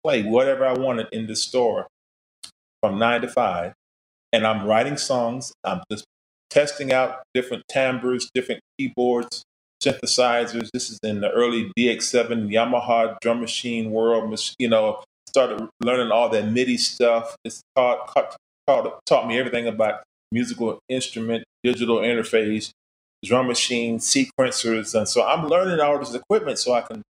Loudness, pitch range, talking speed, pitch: -22 LUFS, 110-125 Hz, 150 wpm, 120 Hz